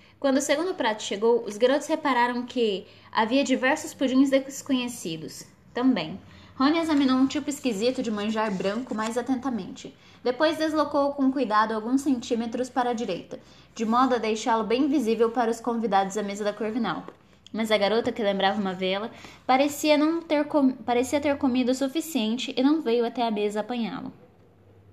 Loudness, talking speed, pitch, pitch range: -25 LUFS, 165 wpm, 245 Hz, 220-275 Hz